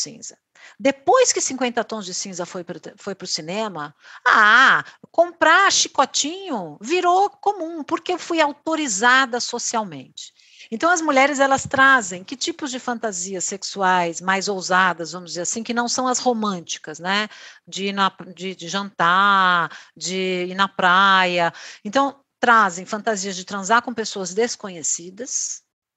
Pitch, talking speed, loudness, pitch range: 220 Hz, 140 wpm, -19 LUFS, 185-275 Hz